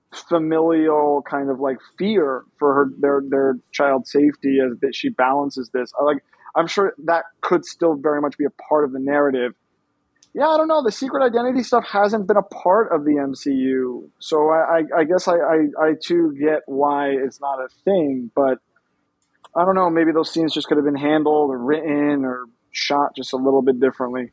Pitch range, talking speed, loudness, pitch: 135-165 Hz, 200 wpm, -19 LUFS, 145 Hz